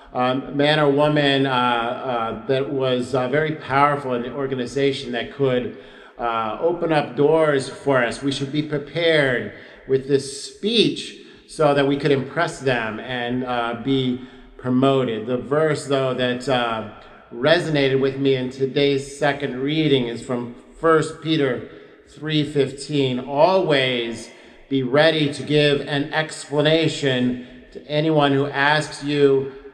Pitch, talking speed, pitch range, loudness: 140 Hz, 135 wpm, 125-150 Hz, -20 LUFS